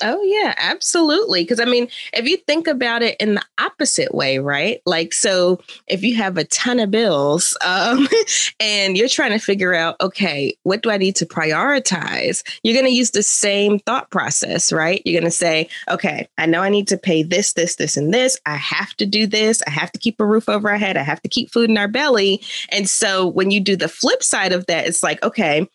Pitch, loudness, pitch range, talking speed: 205 Hz, -17 LUFS, 175-240 Hz, 230 wpm